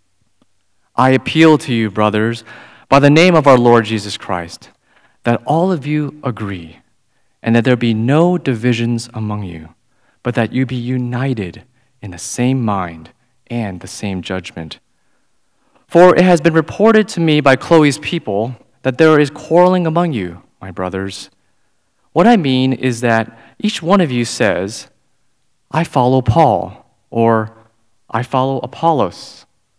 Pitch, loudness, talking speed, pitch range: 125 Hz, -14 LUFS, 150 wpm, 110-150 Hz